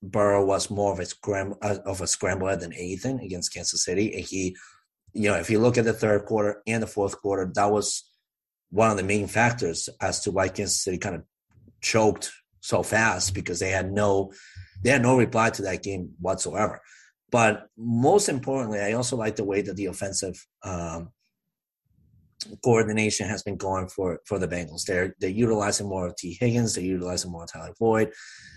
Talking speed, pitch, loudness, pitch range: 190 wpm, 100 Hz, -25 LUFS, 95-110 Hz